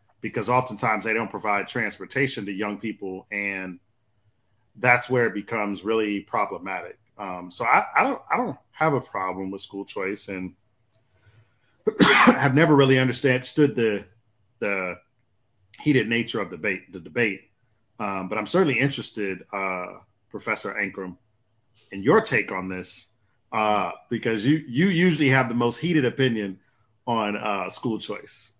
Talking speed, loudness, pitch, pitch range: 145 wpm, -24 LUFS, 110 Hz, 100-120 Hz